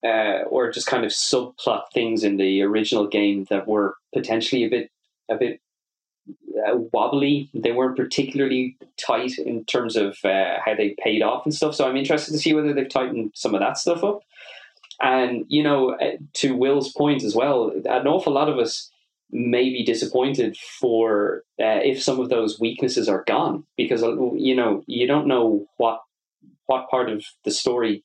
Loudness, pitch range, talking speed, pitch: -22 LUFS, 115-145 Hz, 180 wpm, 130 Hz